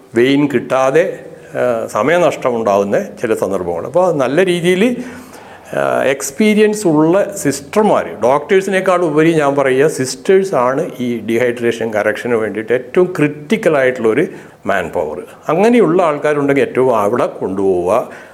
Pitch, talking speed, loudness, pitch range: 155 Hz, 95 wpm, -14 LUFS, 130-195 Hz